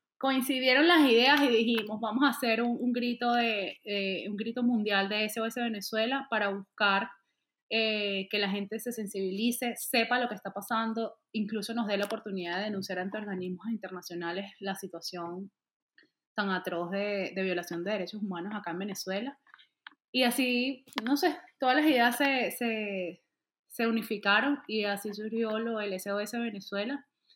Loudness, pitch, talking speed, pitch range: -30 LUFS, 215 Hz, 160 wpm, 195-240 Hz